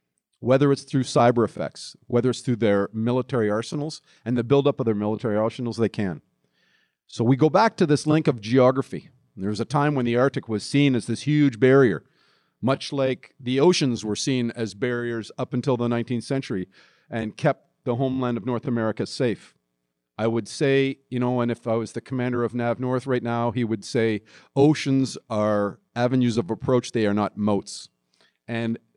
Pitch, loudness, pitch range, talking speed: 120 Hz, -23 LUFS, 110-135 Hz, 190 wpm